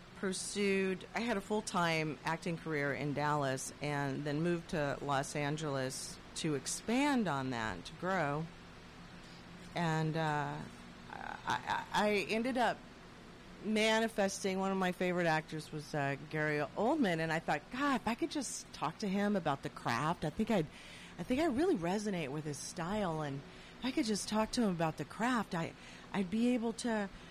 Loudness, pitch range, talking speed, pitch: -36 LUFS, 150-215 Hz, 170 wpm, 175 Hz